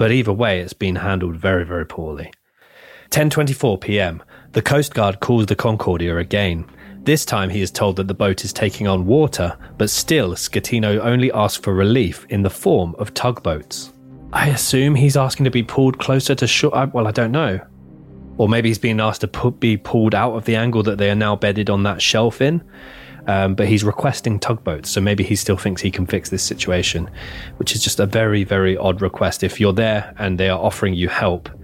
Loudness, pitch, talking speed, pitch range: -18 LUFS, 105 Hz, 205 wpm, 95-120 Hz